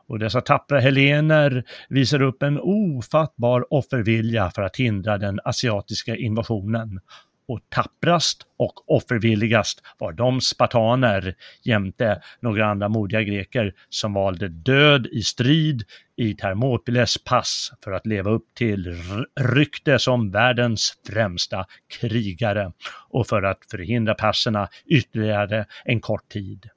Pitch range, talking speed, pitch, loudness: 105-125 Hz, 120 wpm, 115 Hz, -21 LUFS